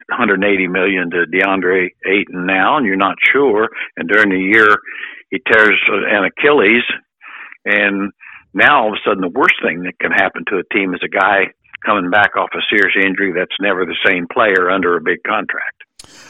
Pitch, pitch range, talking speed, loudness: 95 Hz, 90-100 Hz, 190 wpm, -13 LUFS